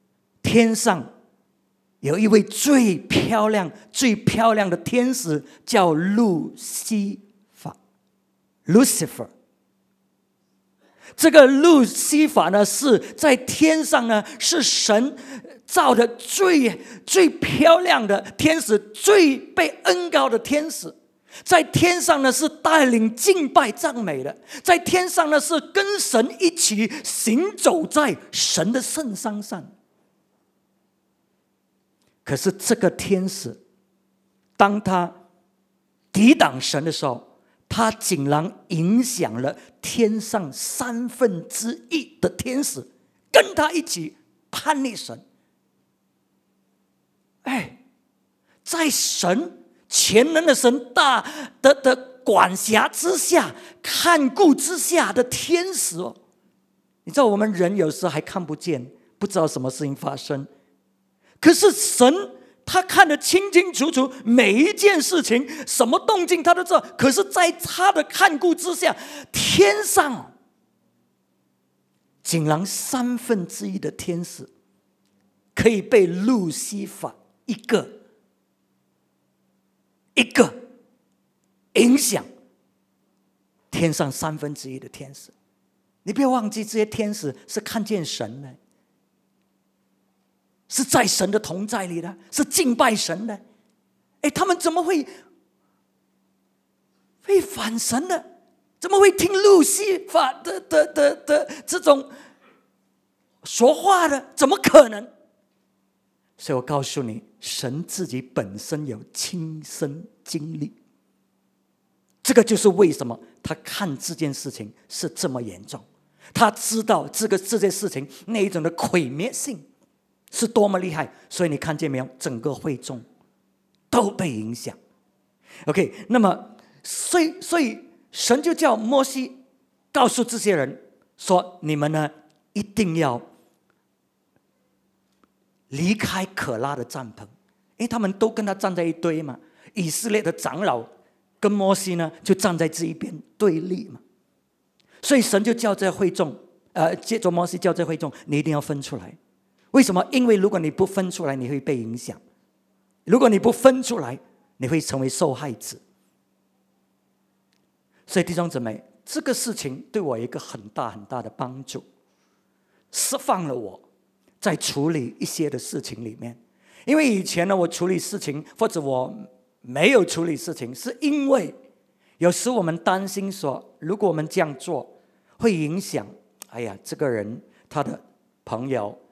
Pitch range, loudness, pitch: 160-275 Hz, -20 LUFS, 210 Hz